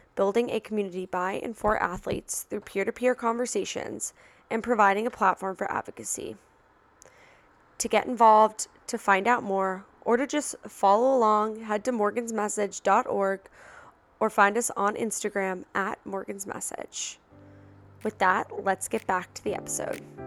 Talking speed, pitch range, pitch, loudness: 140 wpm, 190-230 Hz, 210 Hz, -27 LUFS